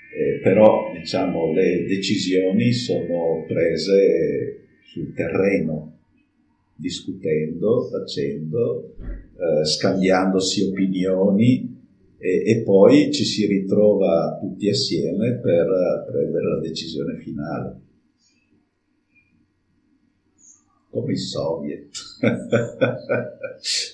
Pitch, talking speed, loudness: 100 Hz, 80 wpm, -20 LUFS